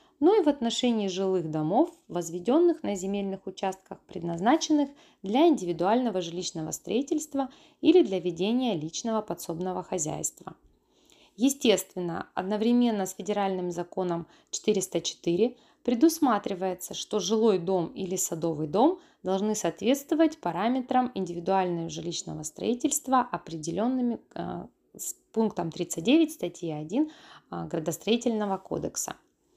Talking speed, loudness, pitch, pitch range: 100 wpm, -28 LUFS, 200 Hz, 175-255 Hz